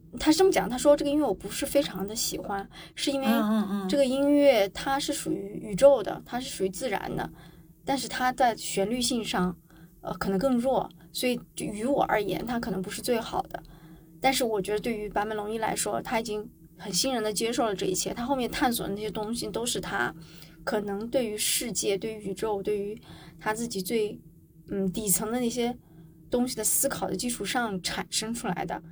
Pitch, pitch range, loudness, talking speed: 215 Hz, 190-250 Hz, -28 LUFS, 295 characters per minute